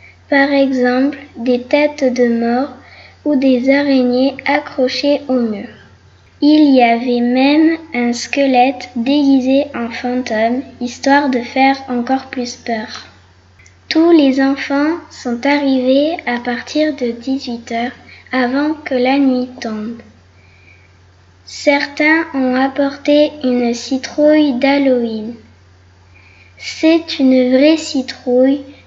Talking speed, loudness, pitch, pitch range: 105 wpm, -14 LUFS, 260 Hz, 240-280 Hz